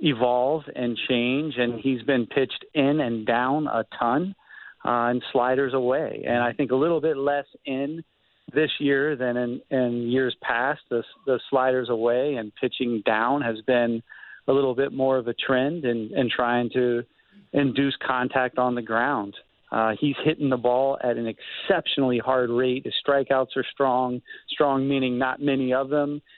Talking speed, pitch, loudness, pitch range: 170 wpm, 130 Hz, -24 LUFS, 120-140 Hz